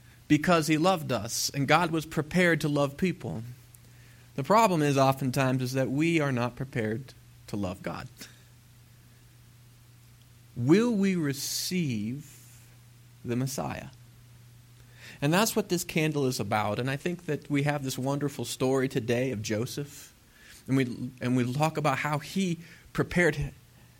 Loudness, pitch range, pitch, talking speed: -28 LUFS, 120-150 Hz, 130 Hz, 145 wpm